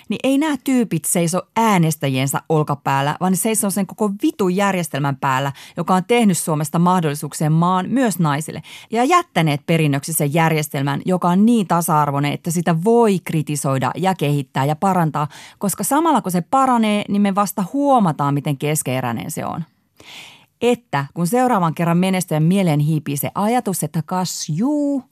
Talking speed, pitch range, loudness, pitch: 155 wpm, 150-205 Hz, -18 LUFS, 175 Hz